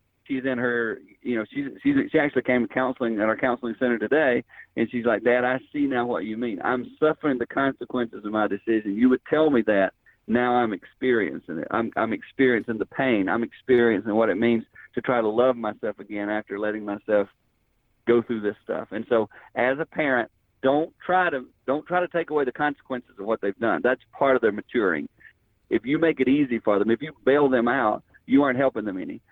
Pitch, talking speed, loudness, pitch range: 125 Hz, 220 wpm, -24 LUFS, 115-135 Hz